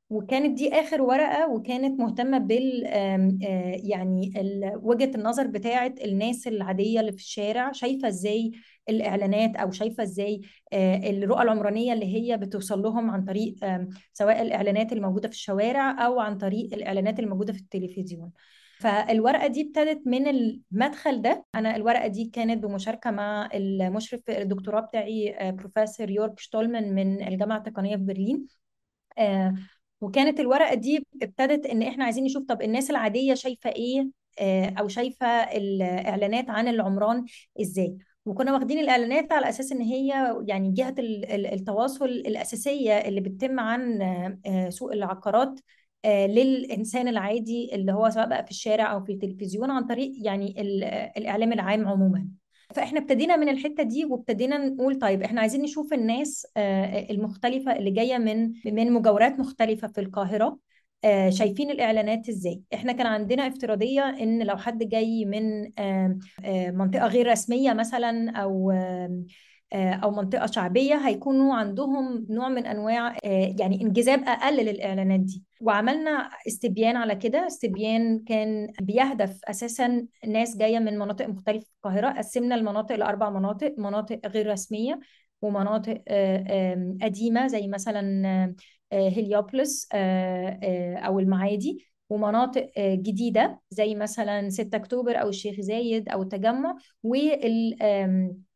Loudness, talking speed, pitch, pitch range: -26 LUFS, 125 wpm, 220 Hz, 200-245 Hz